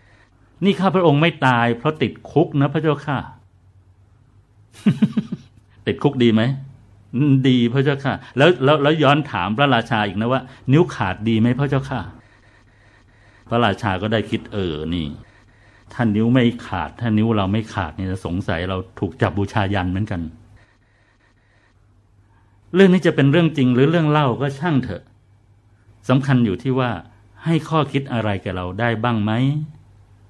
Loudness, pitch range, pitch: -19 LUFS, 100-135 Hz, 115 Hz